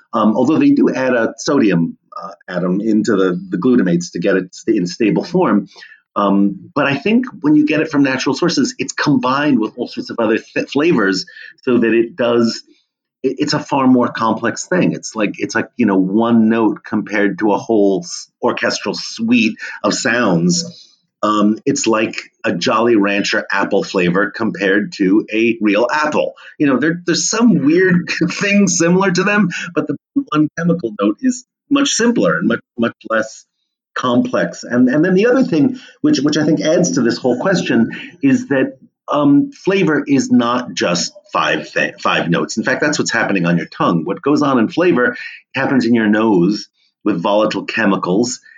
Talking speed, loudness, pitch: 180 wpm, -15 LUFS, 150 Hz